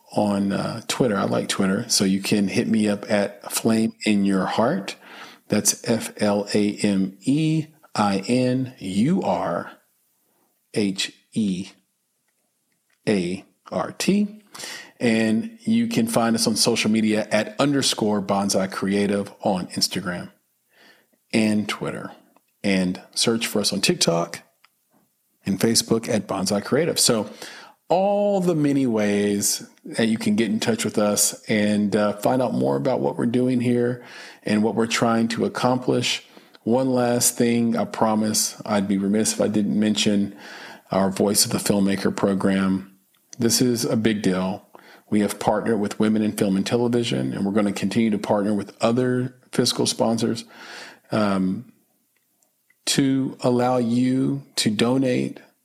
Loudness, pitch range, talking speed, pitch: -22 LUFS, 100-120 Hz, 150 wpm, 110 Hz